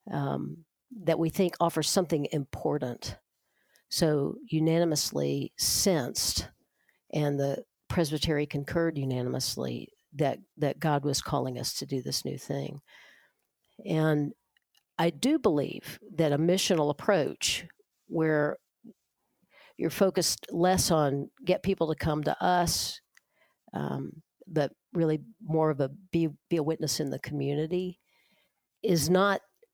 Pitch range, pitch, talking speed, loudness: 145-175 Hz, 155 Hz, 120 wpm, -29 LUFS